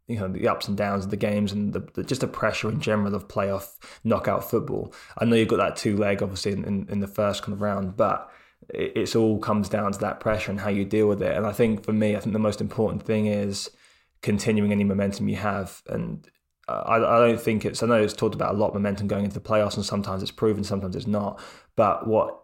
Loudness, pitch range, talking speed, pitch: -25 LUFS, 100-110 Hz, 255 wpm, 105 Hz